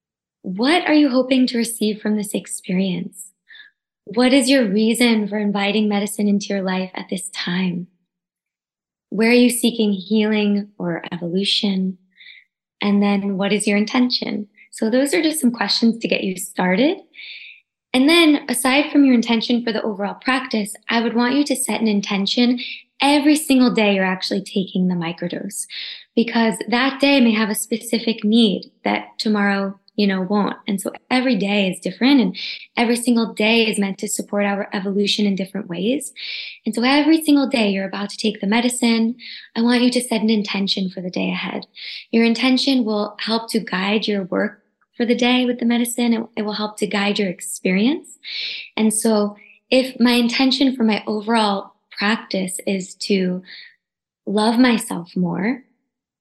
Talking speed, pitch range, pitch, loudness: 170 wpm, 200-245 Hz, 220 Hz, -19 LUFS